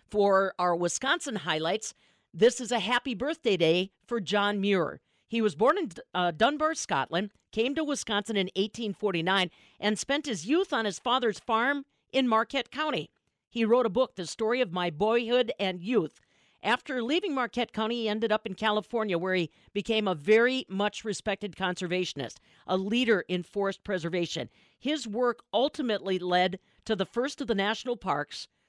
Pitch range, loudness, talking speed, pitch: 190-245 Hz, -29 LUFS, 165 wpm, 215 Hz